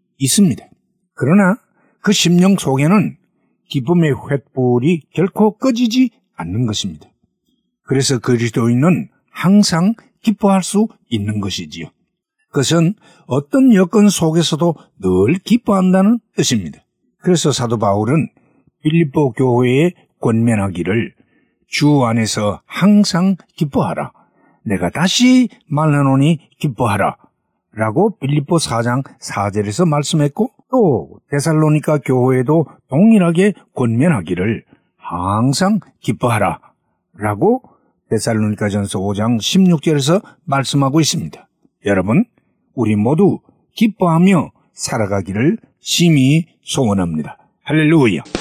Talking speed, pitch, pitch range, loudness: 245 characters per minute, 155 Hz, 120-190 Hz, -15 LUFS